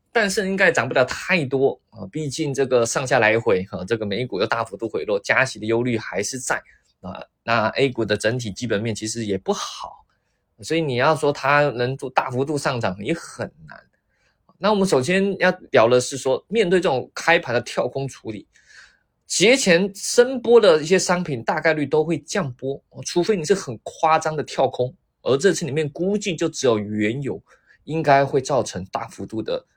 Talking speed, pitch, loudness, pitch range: 270 characters per minute, 145 Hz, -21 LUFS, 125-185 Hz